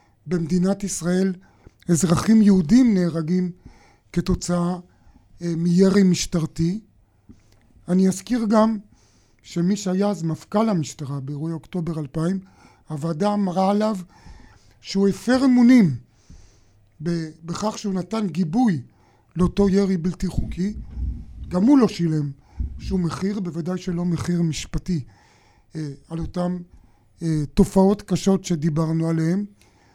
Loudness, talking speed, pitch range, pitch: -22 LUFS, 100 wpm, 150-195 Hz, 175 Hz